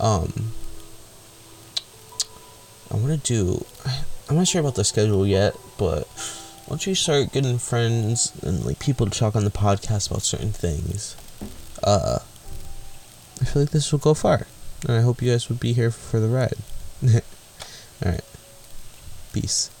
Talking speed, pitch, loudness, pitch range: 155 wpm, 110 Hz, -23 LUFS, 105-125 Hz